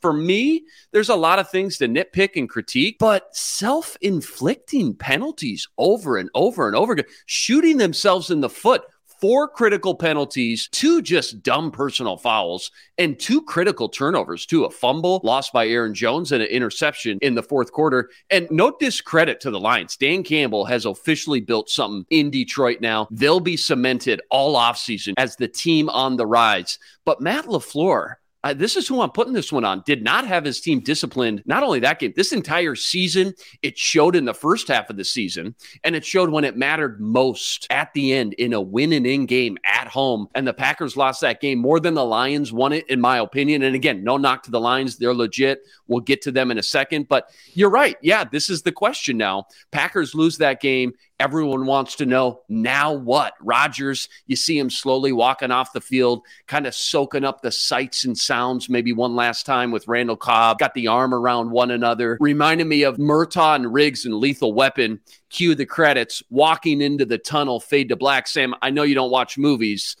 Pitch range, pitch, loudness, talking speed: 125-175 Hz, 140 Hz, -20 LUFS, 200 wpm